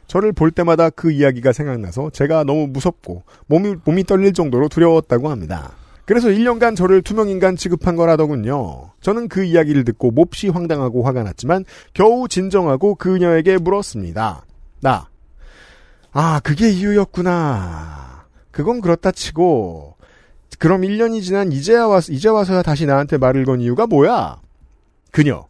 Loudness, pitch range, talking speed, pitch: -16 LUFS, 125-190 Hz, 325 characters per minute, 160 Hz